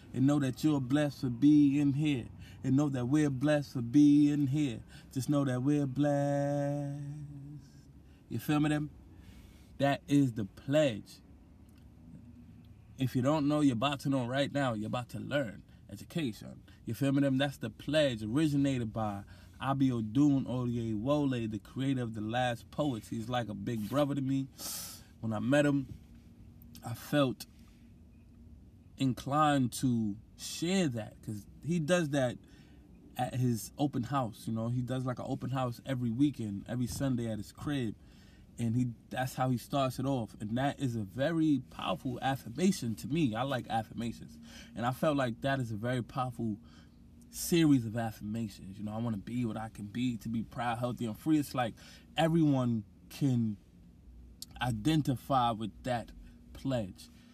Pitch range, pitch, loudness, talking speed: 110-140 Hz, 125 Hz, -32 LUFS, 165 wpm